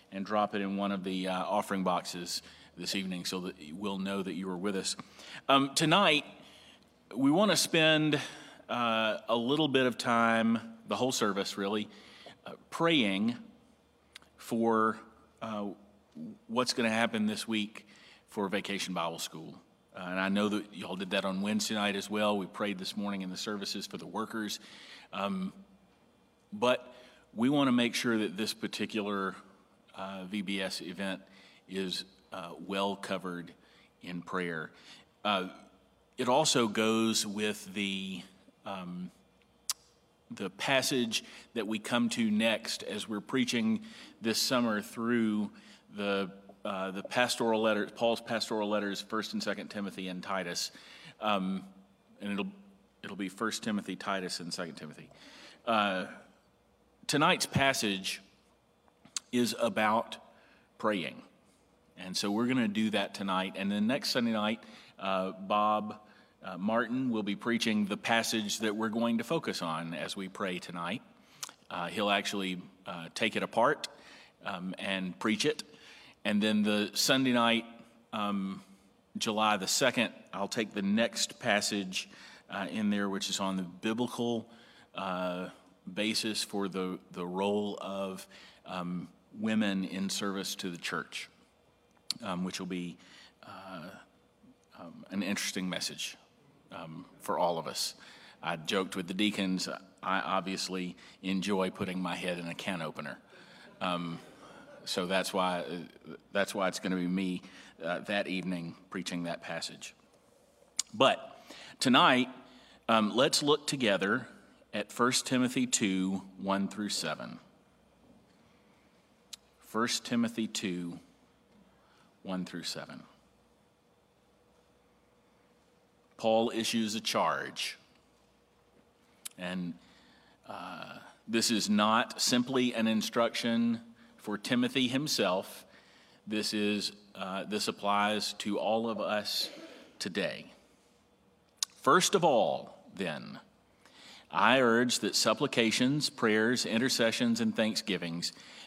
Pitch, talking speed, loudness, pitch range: 105 Hz, 130 wpm, -32 LUFS, 95-115 Hz